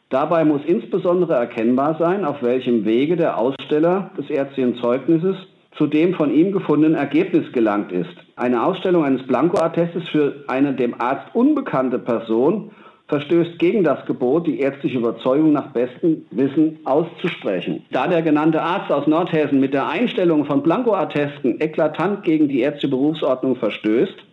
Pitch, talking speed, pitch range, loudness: 155 Hz, 145 wpm, 135-185 Hz, -19 LUFS